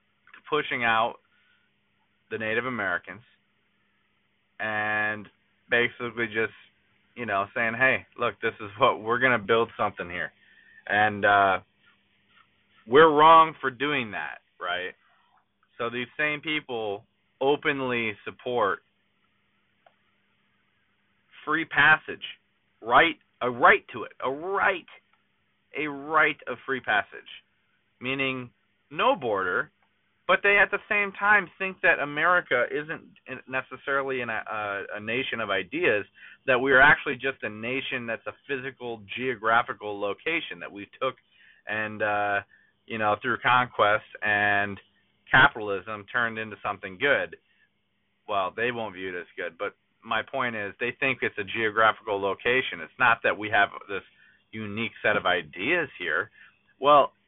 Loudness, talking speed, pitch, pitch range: -25 LUFS, 135 wpm, 120 Hz, 105-135 Hz